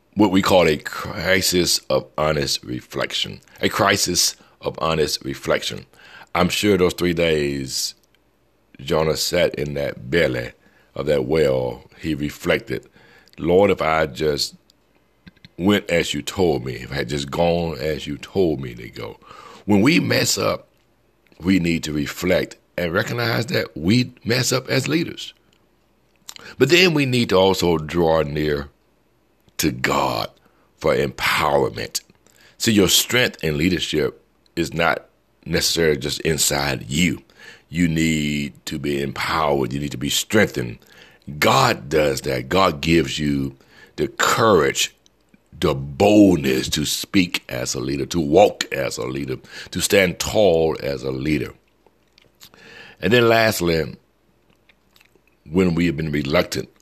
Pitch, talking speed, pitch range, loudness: 80 Hz, 140 wpm, 70-95 Hz, -20 LUFS